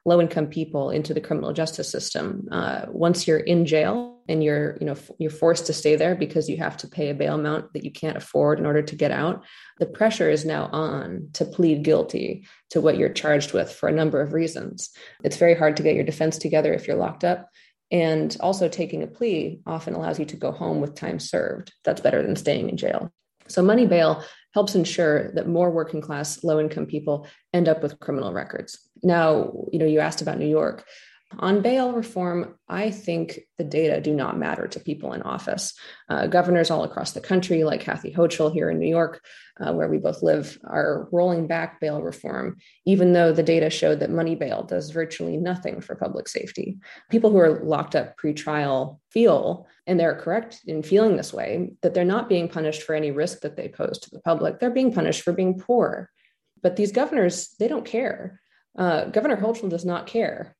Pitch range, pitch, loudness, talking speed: 155-185 Hz, 165 Hz, -23 LUFS, 210 wpm